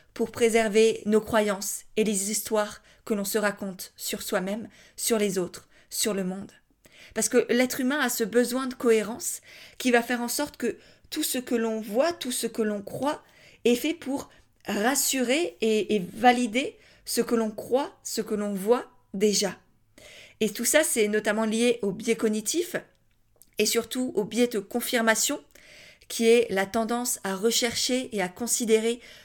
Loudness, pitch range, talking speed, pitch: -26 LUFS, 210-245 Hz, 170 wpm, 230 Hz